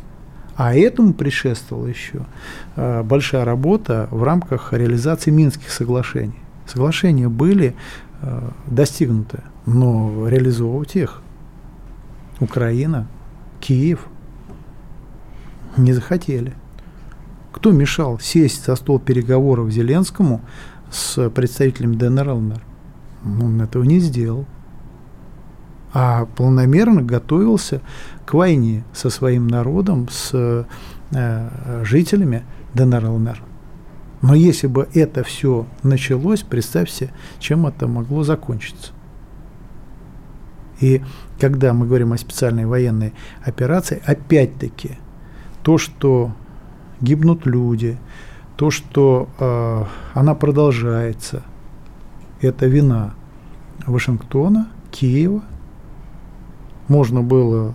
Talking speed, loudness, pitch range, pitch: 85 wpm, -17 LUFS, 120-150 Hz, 130 Hz